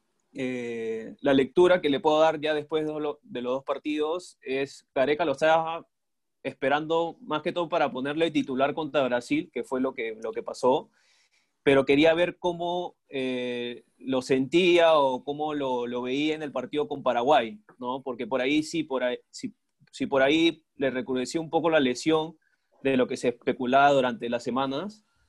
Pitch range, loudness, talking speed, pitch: 130-160 Hz, -26 LUFS, 175 wpm, 145 Hz